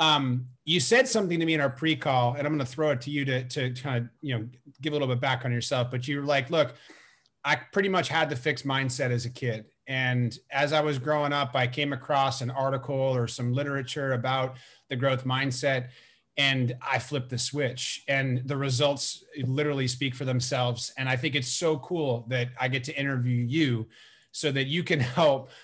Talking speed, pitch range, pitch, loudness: 215 wpm, 125-145 Hz, 135 Hz, -27 LUFS